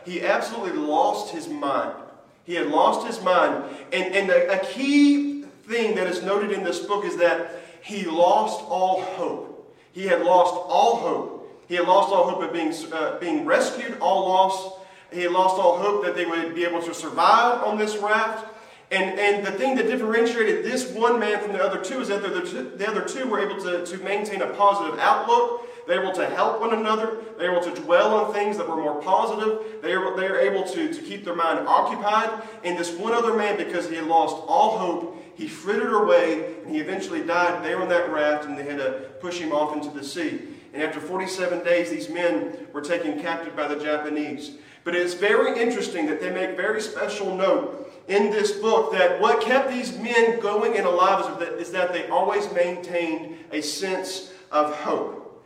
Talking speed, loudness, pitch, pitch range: 210 wpm, -23 LUFS, 190 Hz, 170-220 Hz